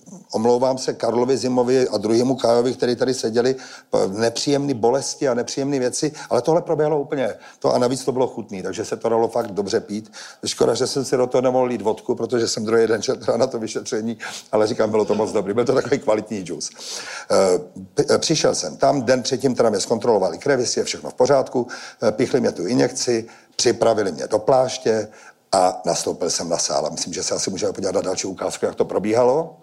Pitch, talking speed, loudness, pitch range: 125 Hz, 195 wpm, -20 LUFS, 115-140 Hz